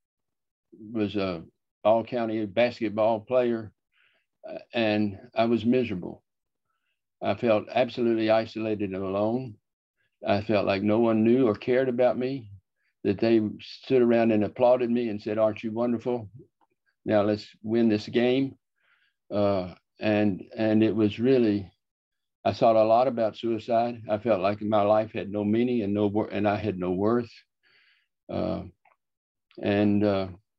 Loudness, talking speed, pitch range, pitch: -26 LUFS, 145 wpm, 105-120 Hz, 110 Hz